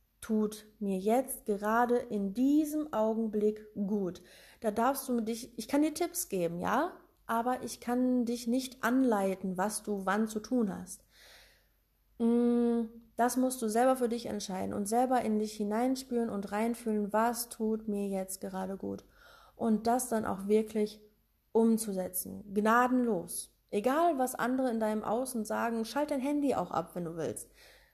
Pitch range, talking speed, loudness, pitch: 210-250 Hz, 155 wpm, -32 LUFS, 225 Hz